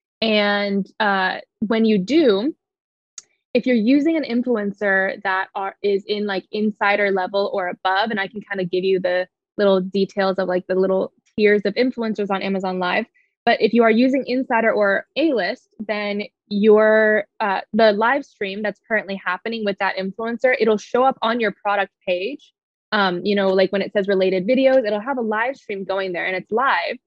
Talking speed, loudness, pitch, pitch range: 190 wpm, -20 LUFS, 205 Hz, 195-230 Hz